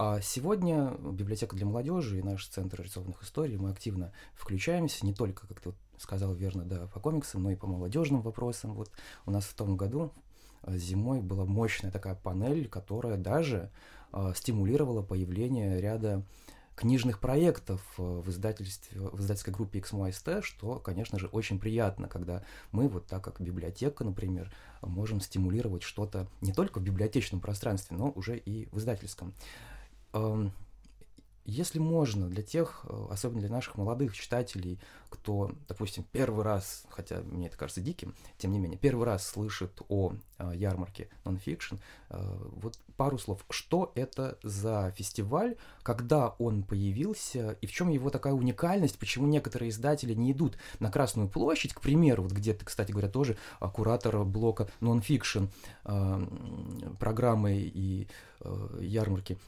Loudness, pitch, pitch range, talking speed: -33 LUFS, 105 Hz, 95-120 Hz, 145 wpm